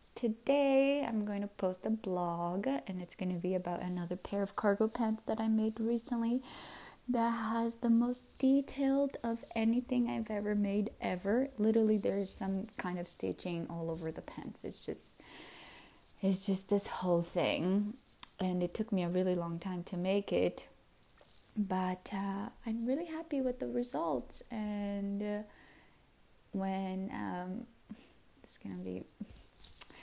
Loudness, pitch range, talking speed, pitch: -35 LUFS, 185-230 Hz, 155 wpm, 205 Hz